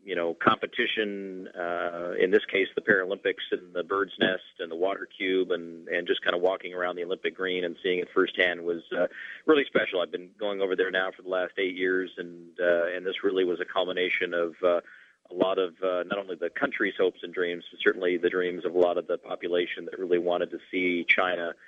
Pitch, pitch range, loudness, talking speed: 90 Hz, 85-95 Hz, -28 LUFS, 230 wpm